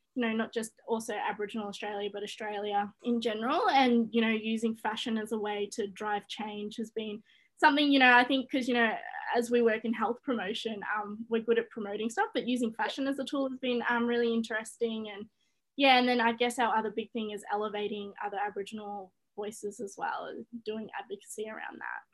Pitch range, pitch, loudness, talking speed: 210-245 Hz, 225 Hz, -31 LUFS, 210 wpm